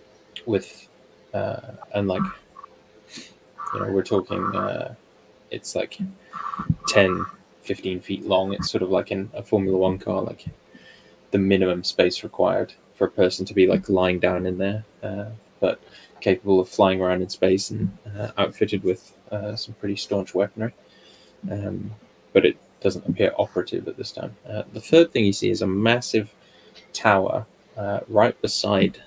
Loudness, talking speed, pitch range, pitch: -23 LUFS, 160 wpm, 95-105 Hz, 100 Hz